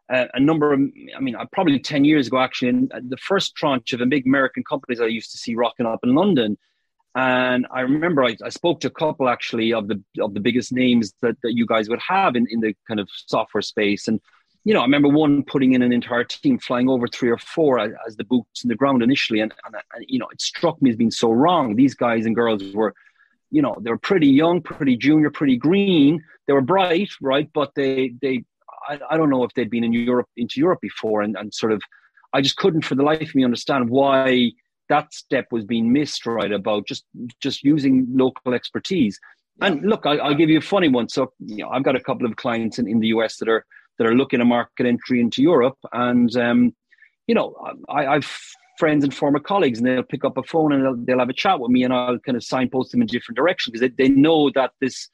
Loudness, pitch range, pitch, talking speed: -20 LUFS, 120-155 Hz, 130 Hz, 240 wpm